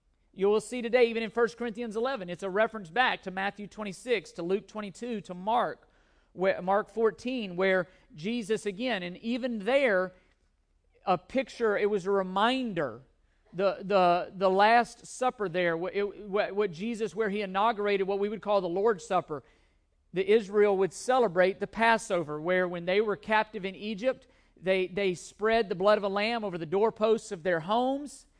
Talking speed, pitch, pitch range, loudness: 175 wpm, 205 Hz, 185-225 Hz, -29 LUFS